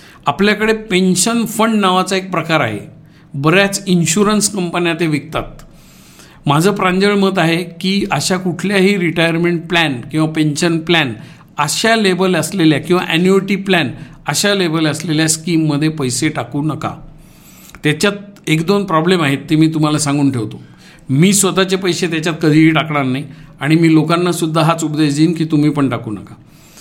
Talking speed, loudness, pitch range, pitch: 150 wpm, -14 LUFS, 150-185 Hz, 165 Hz